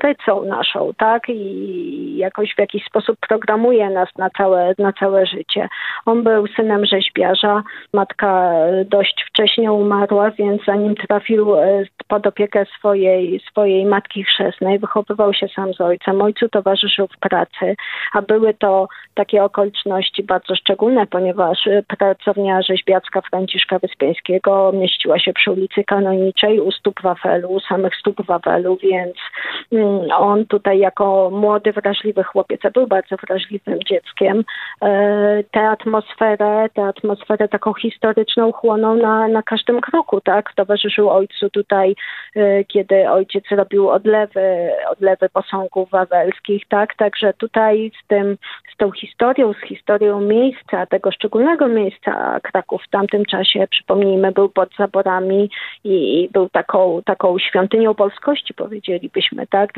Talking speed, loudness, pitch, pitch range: 130 wpm, -16 LUFS, 205 Hz, 190-215 Hz